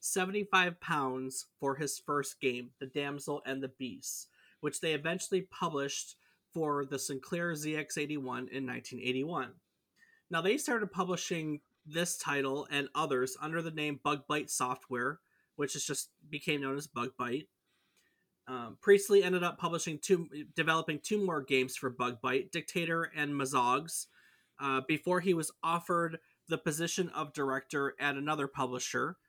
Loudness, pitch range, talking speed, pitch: -34 LUFS, 135-170 Hz, 140 wpm, 150 Hz